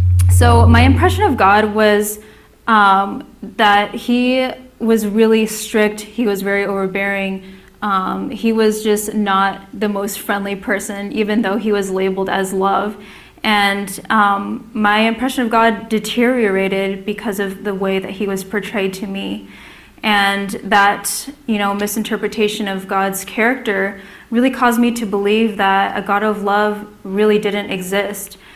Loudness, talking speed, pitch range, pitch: -16 LUFS, 145 wpm, 195-220 Hz, 205 Hz